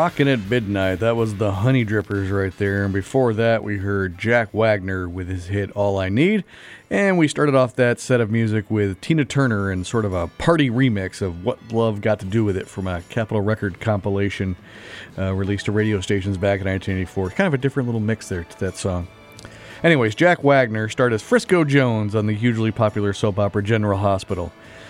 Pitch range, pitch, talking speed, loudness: 100-120 Hz, 110 Hz, 205 wpm, -20 LUFS